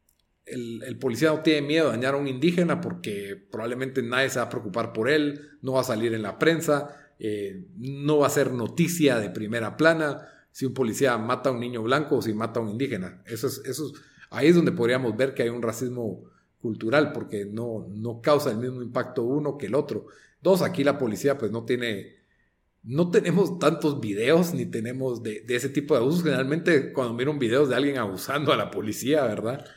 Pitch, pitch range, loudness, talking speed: 130 Hz, 115-145 Hz, -25 LUFS, 210 wpm